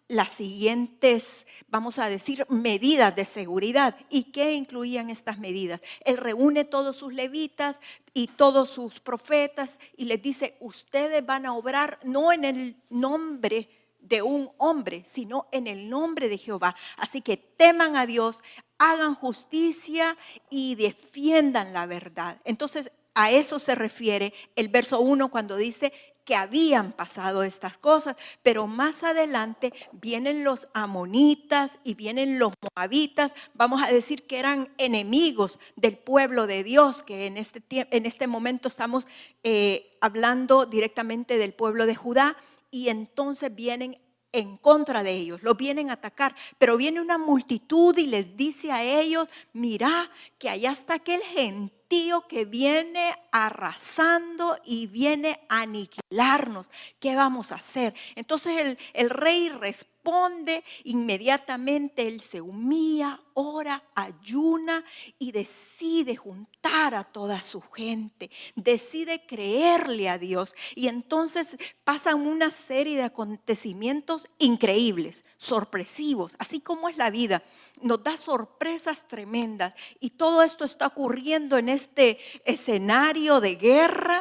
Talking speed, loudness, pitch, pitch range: 135 wpm, -25 LUFS, 260 Hz, 225-295 Hz